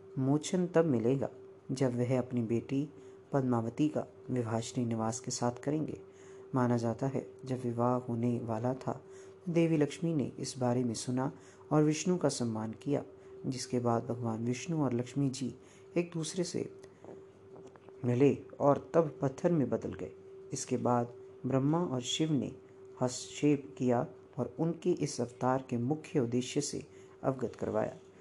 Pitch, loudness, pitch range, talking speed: 130 Hz, -34 LUFS, 120-145 Hz, 145 wpm